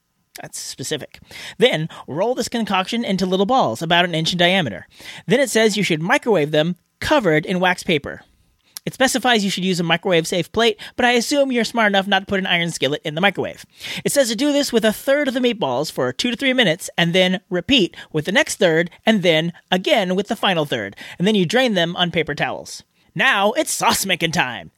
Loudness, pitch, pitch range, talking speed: -18 LUFS, 195 Hz, 170-235 Hz, 225 wpm